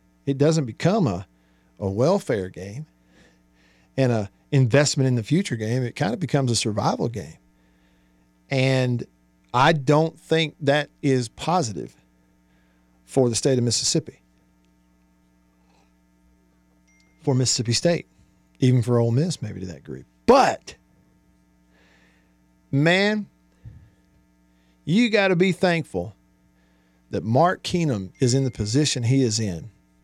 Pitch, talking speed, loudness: 100 Hz, 120 wpm, -22 LUFS